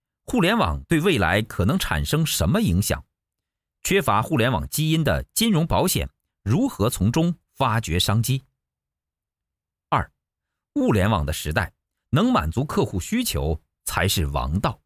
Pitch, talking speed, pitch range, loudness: 100 Hz, 210 characters per minute, 80-130 Hz, -22 LUFS